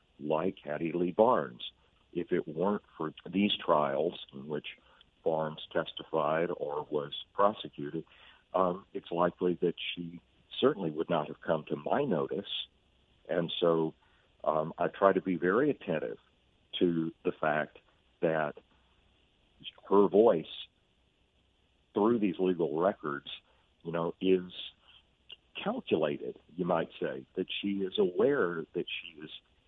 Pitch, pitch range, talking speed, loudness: 85 Hz, 80-95 Hz, 125 wpm, -32 LUFS